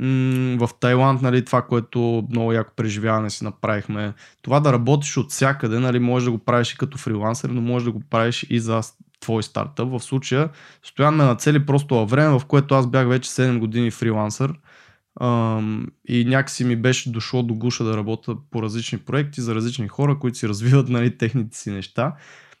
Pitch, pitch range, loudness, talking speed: 120 Hz, 115-130 Hz, -21 LUFS, 185 wpm